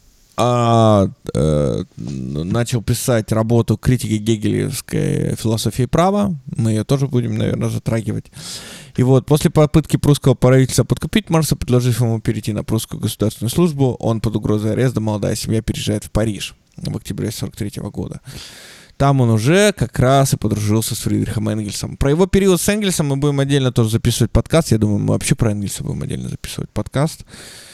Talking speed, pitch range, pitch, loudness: 160 wpm, 110-140 Hz, 120 Hz, -17 LUFS